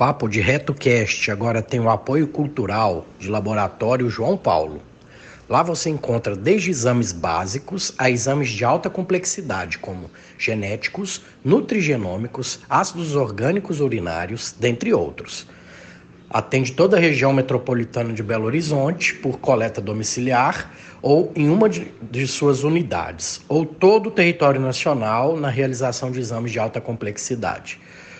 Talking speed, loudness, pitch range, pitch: 130 wpm, -20 LUFS, 110-150 Hz, 125 Hz